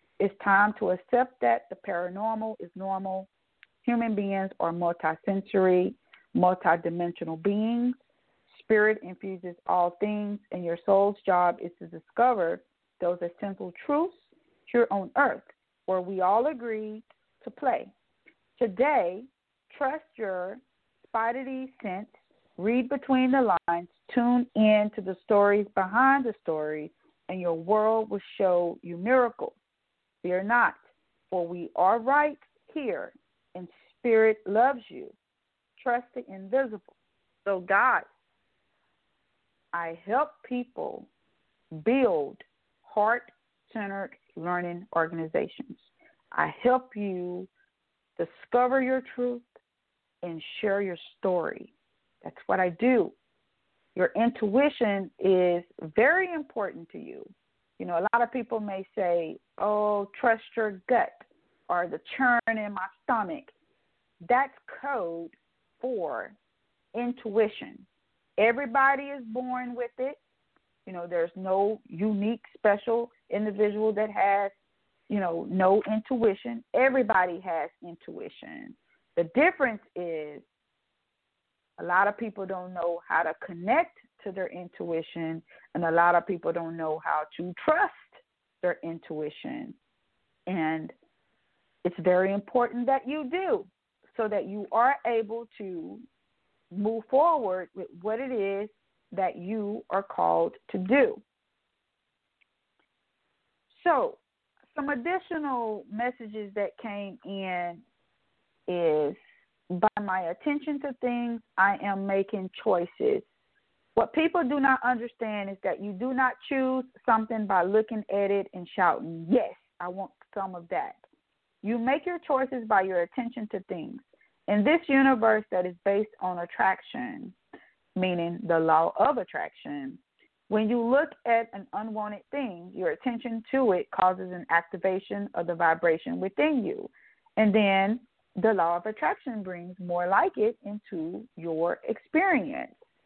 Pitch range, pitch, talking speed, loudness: 180-250 Hz, 210 Hz, 125 wpm, -28 LUFS